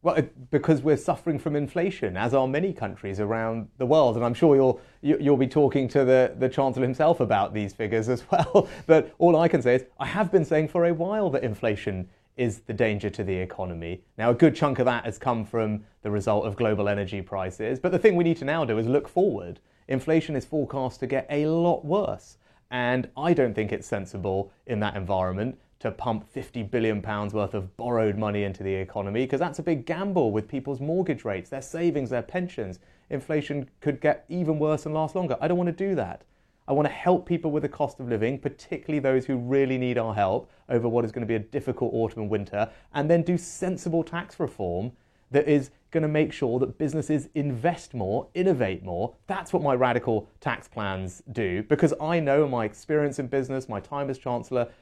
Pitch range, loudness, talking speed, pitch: 110-155 Hz, -26 LUFS, 215 wpm, 130 Hz